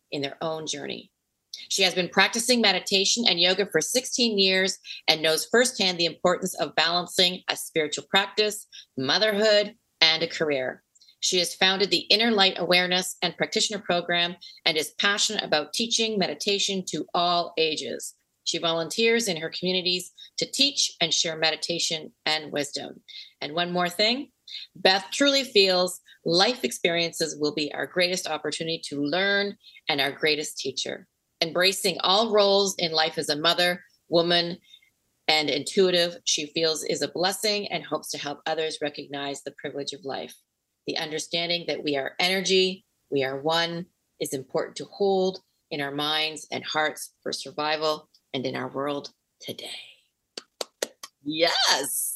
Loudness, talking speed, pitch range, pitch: -24 LUFS, 150 wpm, 155-195 Hz, 175 Hz